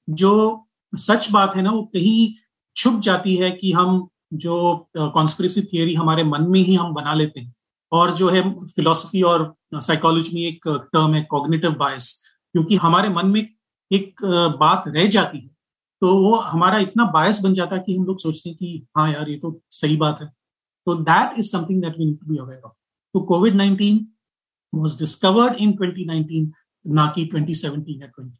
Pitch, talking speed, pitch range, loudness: 175 Hz, 170 wpm, 155-195 Hz, -19 LUFS